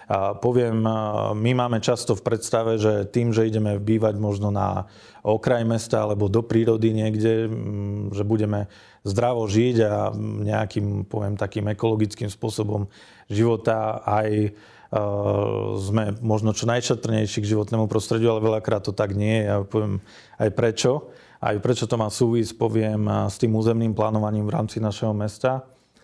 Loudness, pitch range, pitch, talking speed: -23 LUFS, 105-115 Hz, 110 Hz, 145 wpm